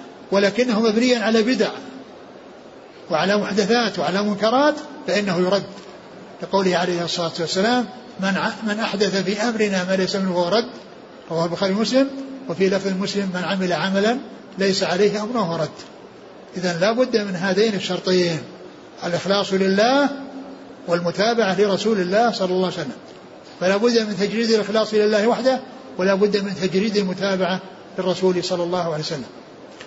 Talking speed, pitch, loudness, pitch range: 140 wpm, 200 Hz, -20 LUFS, 185-225 Hz